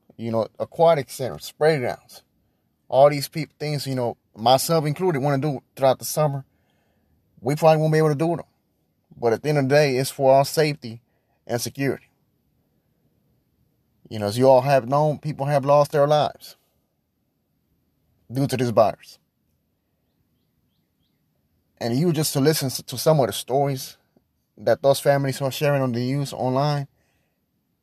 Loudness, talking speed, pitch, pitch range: -21 LUFS, 165 wpm, 135 Hz, 120-150 Hz